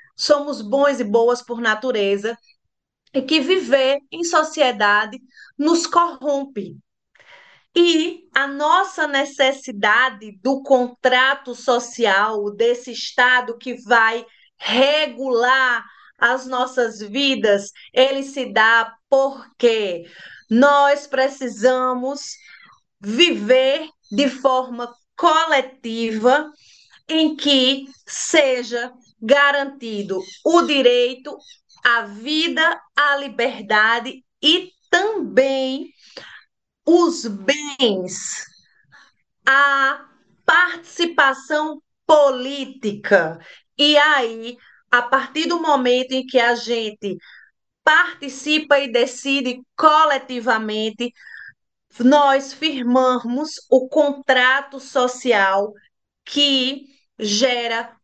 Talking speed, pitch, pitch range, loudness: 80 wpm, 260 Hz, 240-285 Hz, -18 LUFS